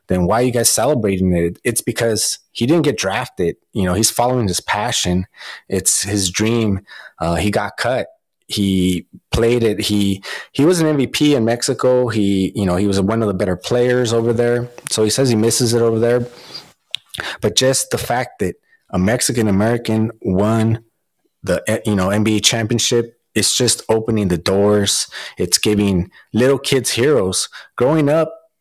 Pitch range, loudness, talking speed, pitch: 100-120 Hz, -17 LUFS, 170 wpm, 110 Hz